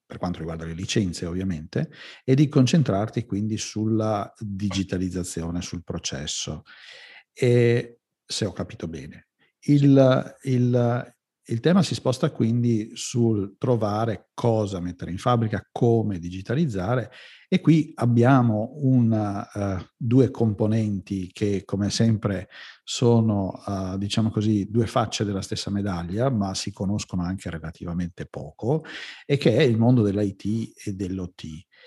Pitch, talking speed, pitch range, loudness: 110 Hz, 125 wpm, 95-120 Hz, -24 LUFS